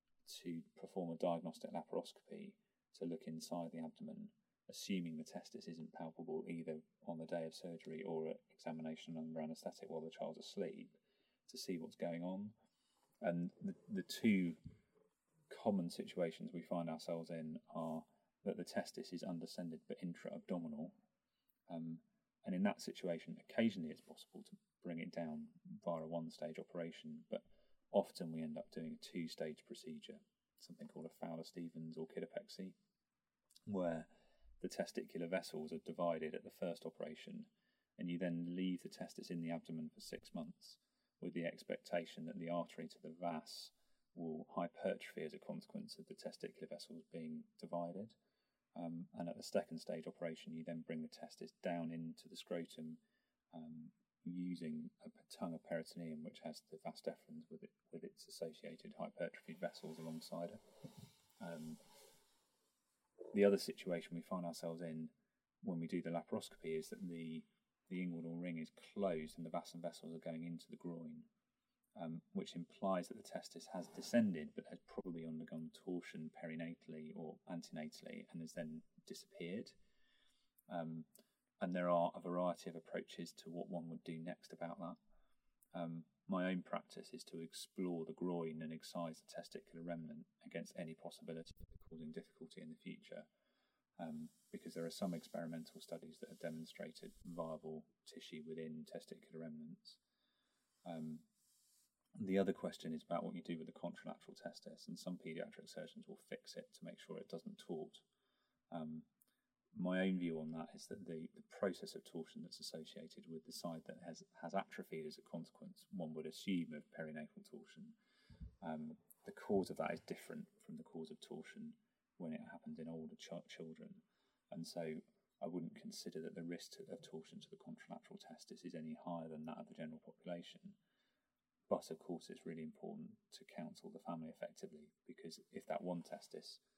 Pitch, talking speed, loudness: 85 Hz, 170 wpm, -48 LUFS